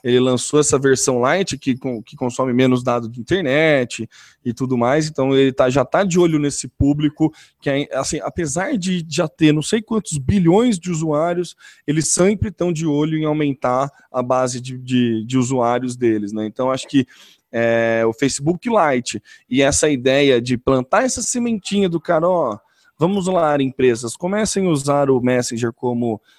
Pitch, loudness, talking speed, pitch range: 140 Hz, -18 LUFS, 175 wpm, 125-170 Hz